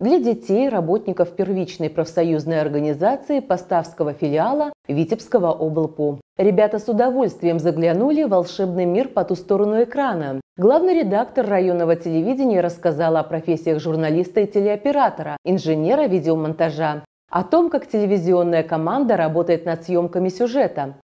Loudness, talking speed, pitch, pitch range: -20 LUFS, 120 wpm, 175 Hz, 160-215 Hz